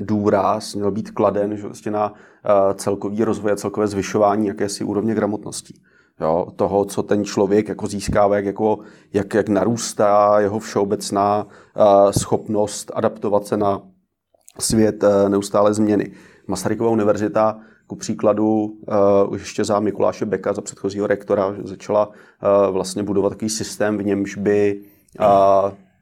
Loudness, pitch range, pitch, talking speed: -19 LUFS, 100-105 Hz, 105 Hz, 140 wpm